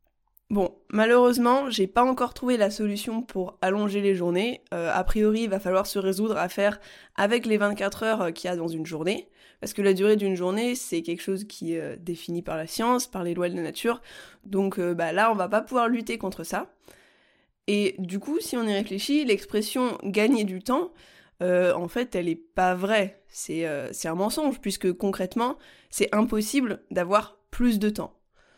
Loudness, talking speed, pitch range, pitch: -26 LUFS, 200 wpm, 185-230 Hz, 200 Hz